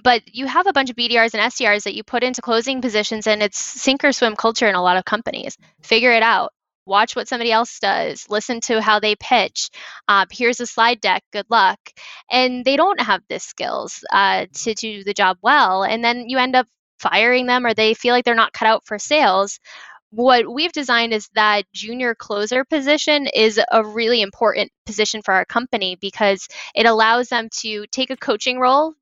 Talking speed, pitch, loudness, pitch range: 210 wpm, 230 Hz, -17 LUFS, 210-250 Hz